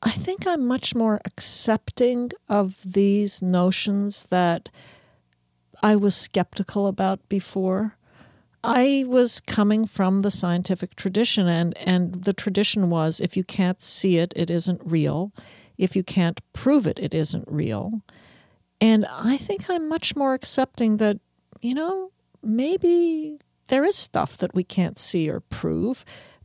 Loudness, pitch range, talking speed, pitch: -22 LUFS, 180-235 Hz, 145 wpm, 200 Hz